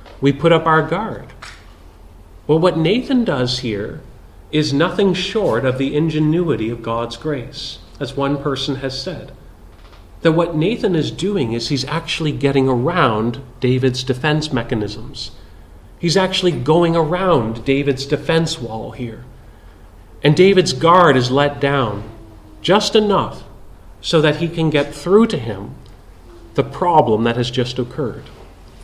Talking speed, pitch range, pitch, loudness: 140 wpm, 110-160 Hz, 135 Hz, -17 LUFS